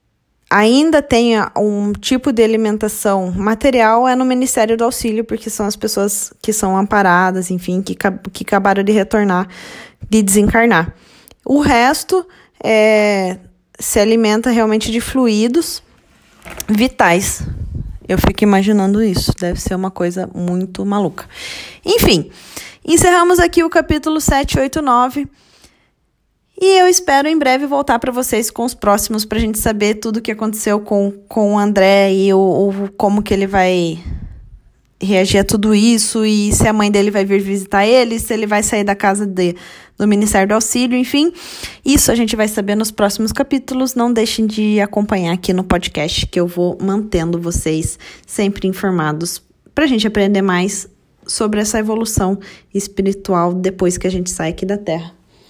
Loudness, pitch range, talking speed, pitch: -14 LUFS, 195-235 Hz, 160 wpm, 210 Hz